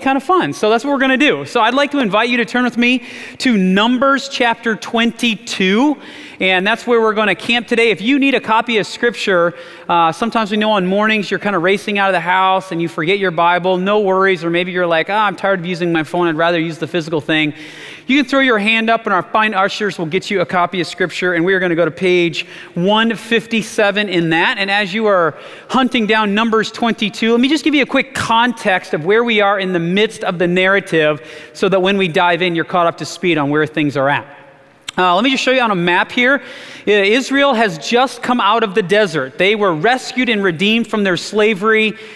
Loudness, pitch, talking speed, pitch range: -14 LUFS, 205 Hz, 245 wpm, 175-230 Hz